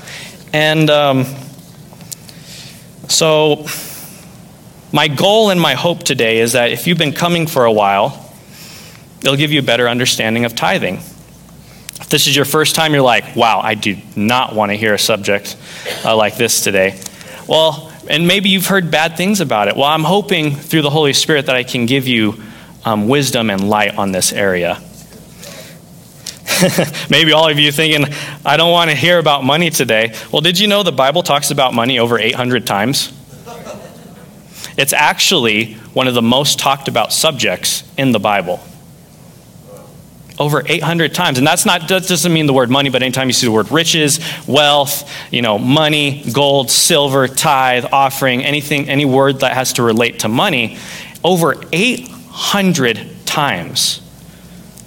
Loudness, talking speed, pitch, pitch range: -13 LUFS, 165 wpm, 145 Hz, 125-160 Hz